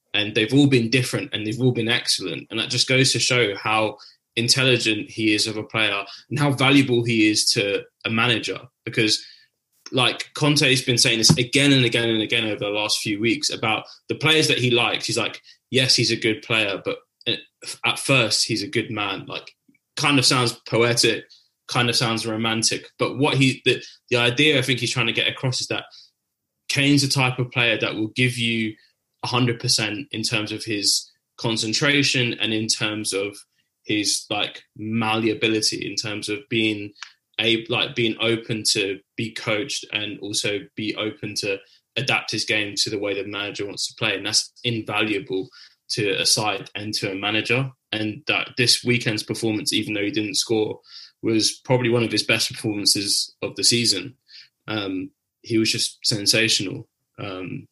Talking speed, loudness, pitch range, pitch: 185 wpm, -21 LUFS, 110-125 Hz, 115 Hz